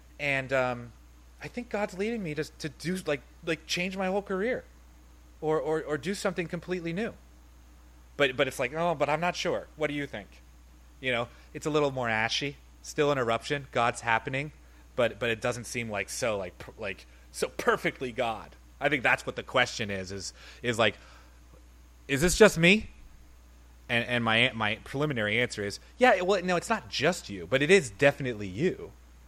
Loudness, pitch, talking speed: -28 LUFS, 125 Hz, 195 wpm